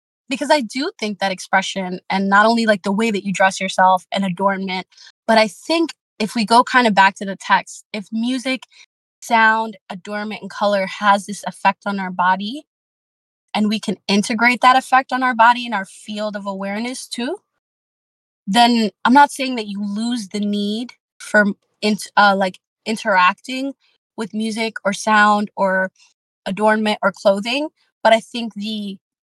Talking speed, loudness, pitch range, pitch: 170 wpm, -18 LUFS, 195-235 Hz, 210 Hz